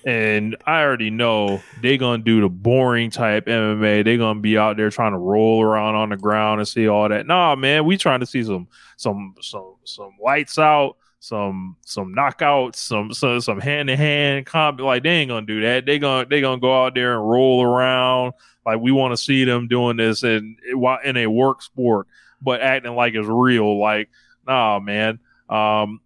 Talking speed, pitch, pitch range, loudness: 205 wpm, 120 Hz, 110-130 Hz, -18 LUFS